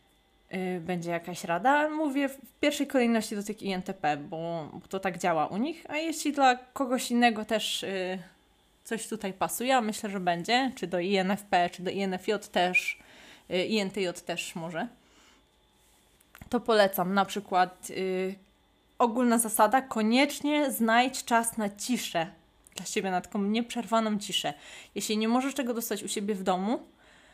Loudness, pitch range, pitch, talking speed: -29 LUFS, 180-240 Hz, 205 Hz, 145 wpm